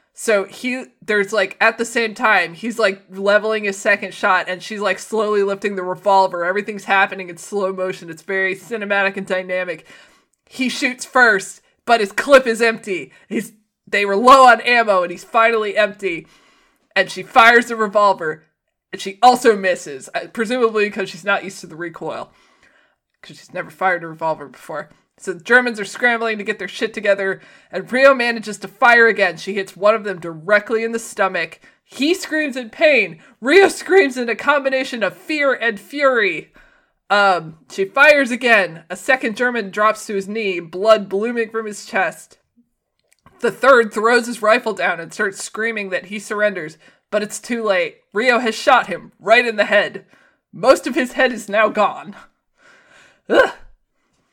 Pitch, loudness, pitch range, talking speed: 215 Hz, -17 LUFS, 195-245 Hz, 175 wpm